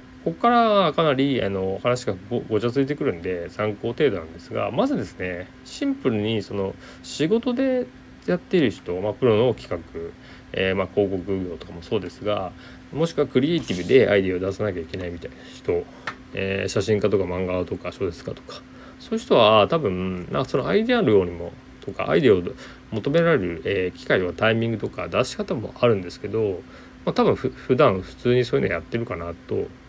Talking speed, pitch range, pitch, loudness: 410 characters per minute, 95-135 Hz, 105 Hz, -23 LUFS